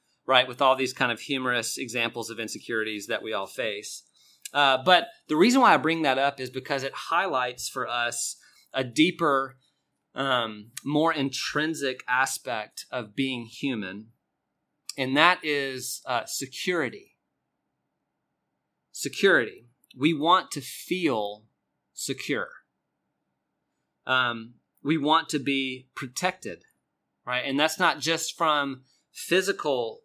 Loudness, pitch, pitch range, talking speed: -26 LUFS, 135 Hz, 125-155 Hz, 125 wpm